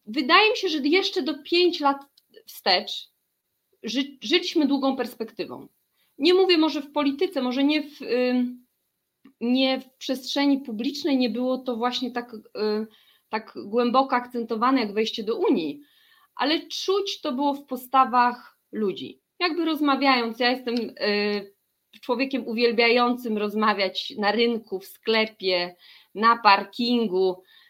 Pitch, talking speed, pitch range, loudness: 250 Hz, 125 wpm, 225-295 Hz, -24 LUFS